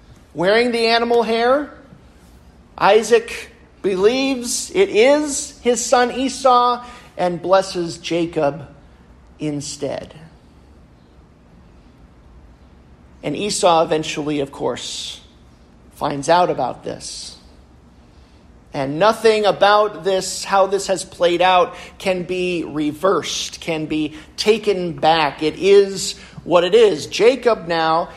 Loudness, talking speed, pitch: -18 LUFS, 100 wpm, 170 Hz